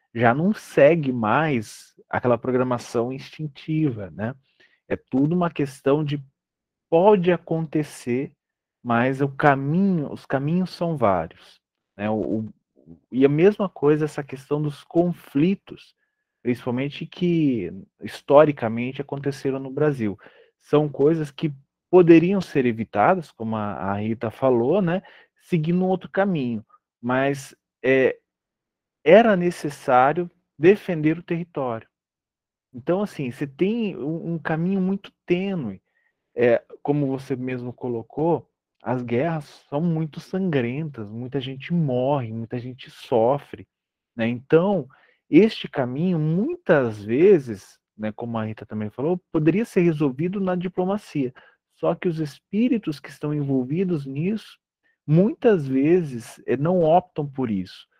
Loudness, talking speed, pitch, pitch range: -22 LUFS, 125 wpm, 150 Hz, 125-180 Hz